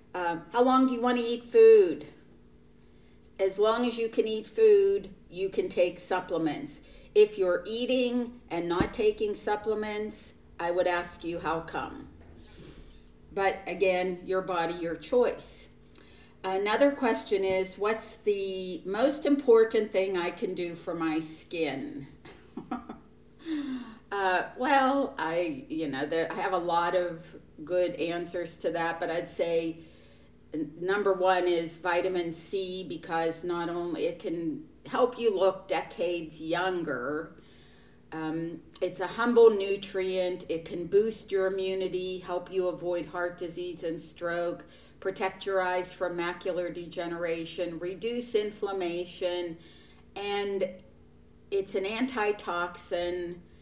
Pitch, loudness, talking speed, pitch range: 185 Hz, -29 LUFS, 130 wpm, 170-220 Hz